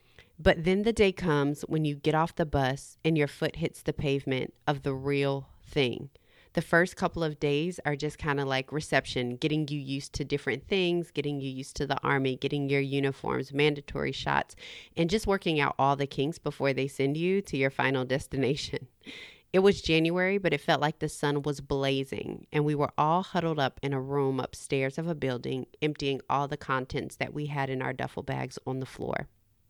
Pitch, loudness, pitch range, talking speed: 145 Hz, -29 LUFS, 135-155 Hz, 205 wpm